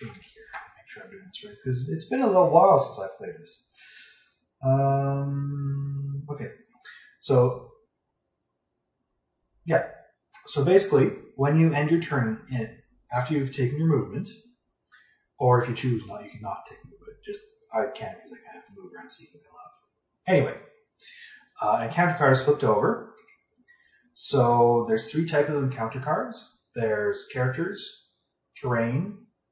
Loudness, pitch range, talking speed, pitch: -25 LUFS, 125-175 Hz, 155 wpm, 140 Hz